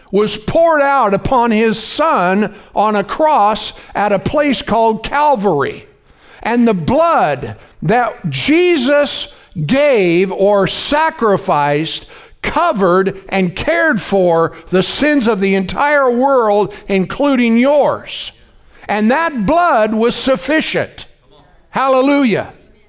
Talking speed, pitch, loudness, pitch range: 105 wpm, 225 Hz, -13 LUFS, 195-285 Hz